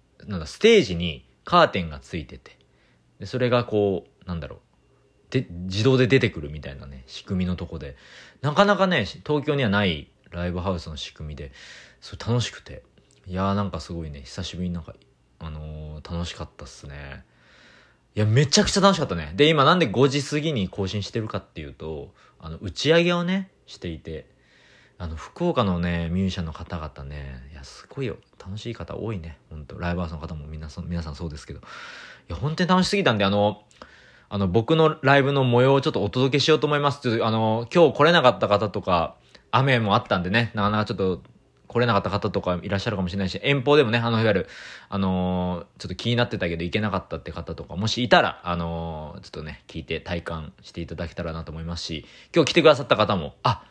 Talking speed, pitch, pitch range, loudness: 420 characters per minute, 100 Hz, 85-120 Hz, -23 LUFS